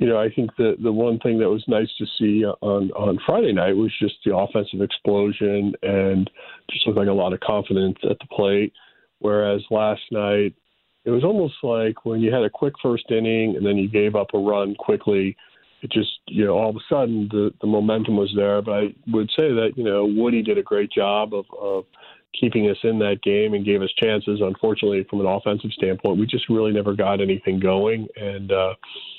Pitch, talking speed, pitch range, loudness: 105 Hz, 215 wpm, 100-110 Hz, -21 LUFS